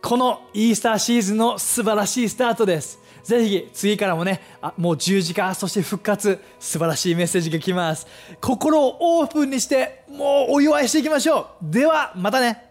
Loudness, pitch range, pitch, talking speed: -20 LUFS, 190-265 Hz, 225 Hz, 385 characters per minute